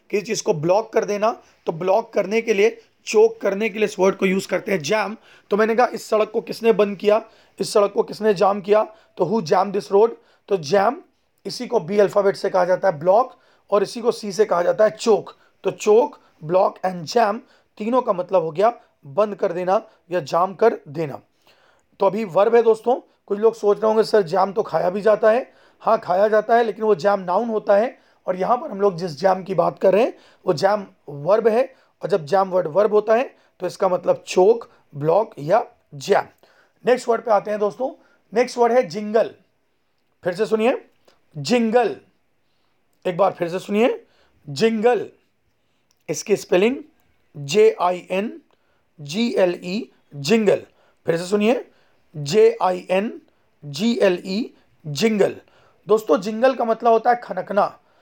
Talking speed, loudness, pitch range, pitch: 190 wpm, -20 LUFS, 190-230 Hz, 210 Hz